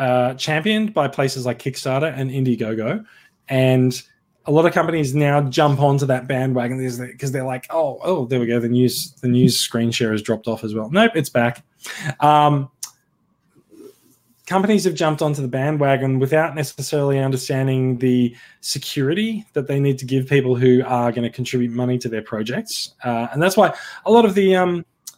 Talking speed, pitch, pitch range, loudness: 180 wpm, 135 Hz, 125-155 Hz, -19 LUFS